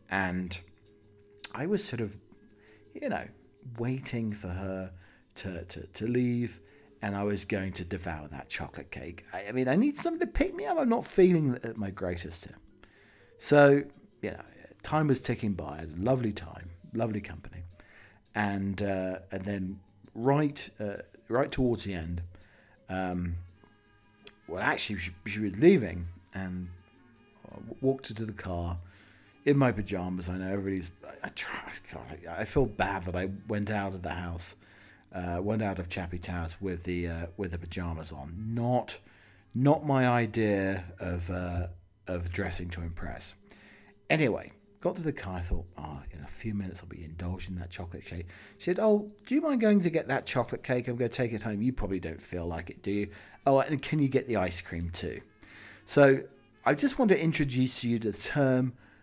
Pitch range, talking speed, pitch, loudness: 90-120 Hz, 185 wpm, 100 Hz, -31 LUFS